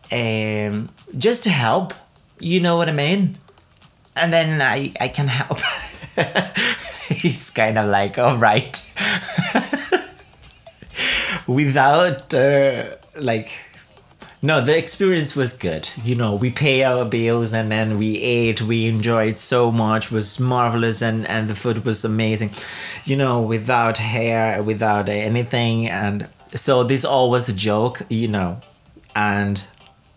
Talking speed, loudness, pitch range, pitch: 135 wpm, -19 LUFS, 110-140 Hz, 120 Hz